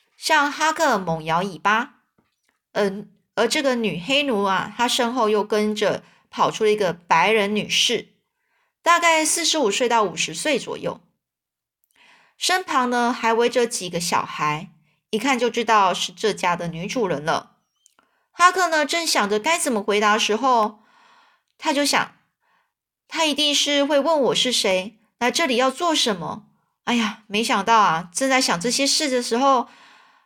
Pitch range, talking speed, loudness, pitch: 210-300 Hz, 225 characters per minute, -20 LUFS, 240 Hz